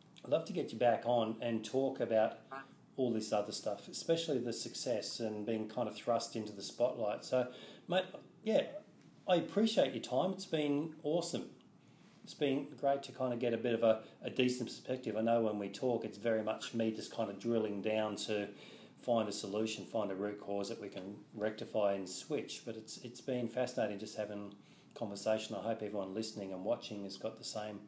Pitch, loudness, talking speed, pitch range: 115 Hz, -37 LUFS, 205 wpm, 105-130 Hz